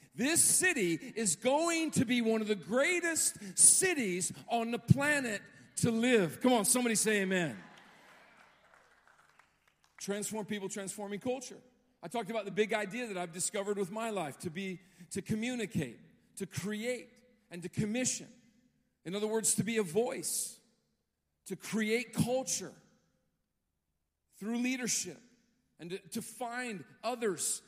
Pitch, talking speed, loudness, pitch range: 220 Hz, 135 wpm, -32 LUFS, 190-245 Hz